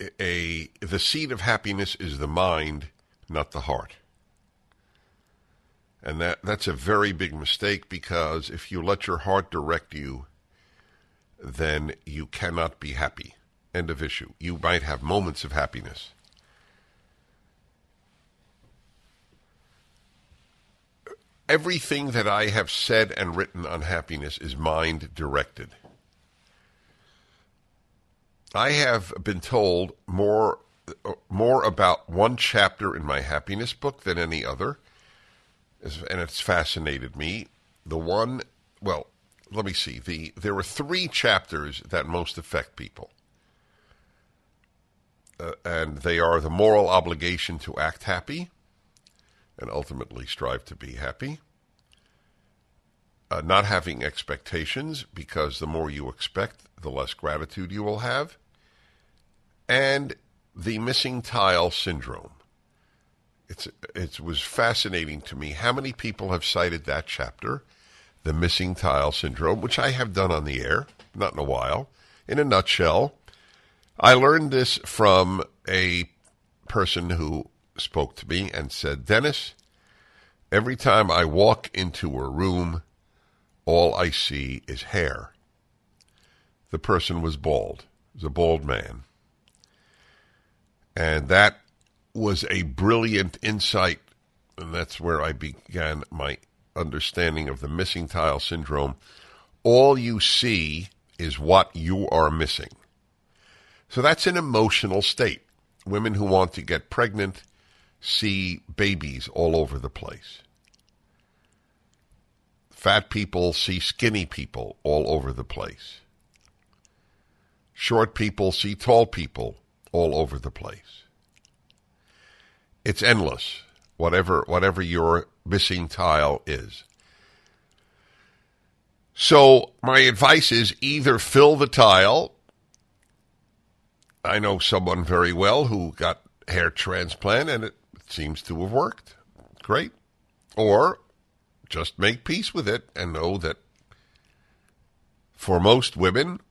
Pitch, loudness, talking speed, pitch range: 90 Hz, -23 LUFS, 120 wpm, 80-105 Hz